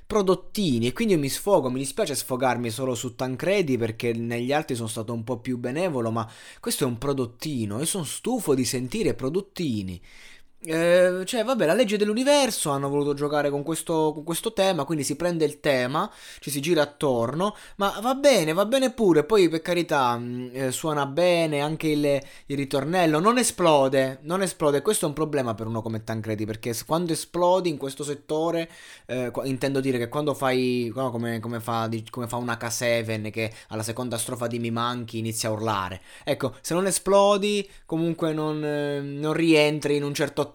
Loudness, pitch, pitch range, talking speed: -25 LUFS, 145 Hz, 120-170 Hz, 185 wpm